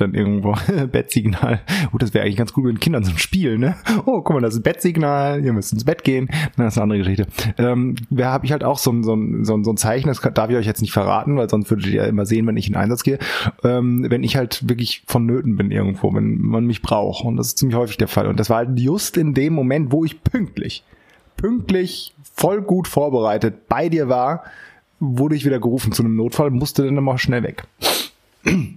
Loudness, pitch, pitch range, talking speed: -19 LUFS, 125 Hz, 110-145 Hz, 235 wpm